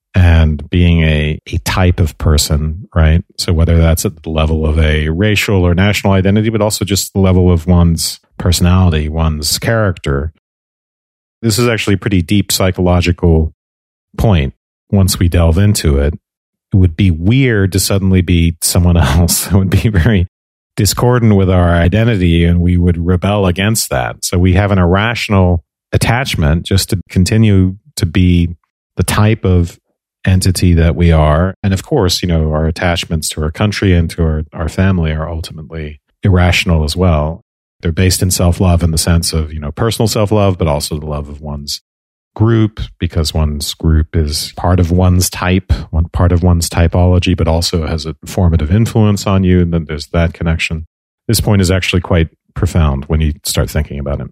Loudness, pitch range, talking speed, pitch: -13 LUFS, 80-95 Hz, 180 wpm, 90 Hz